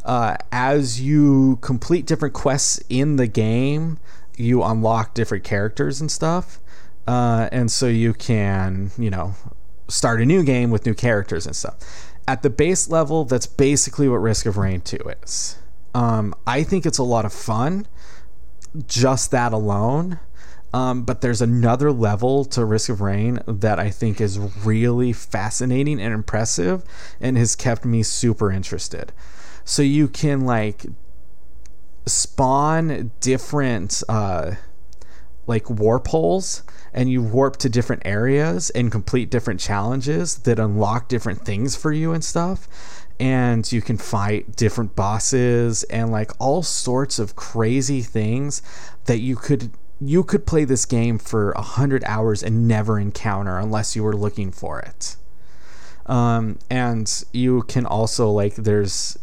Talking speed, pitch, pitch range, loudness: 150 wpm, 115 Hz, 105-130 Hz, -20 LUFS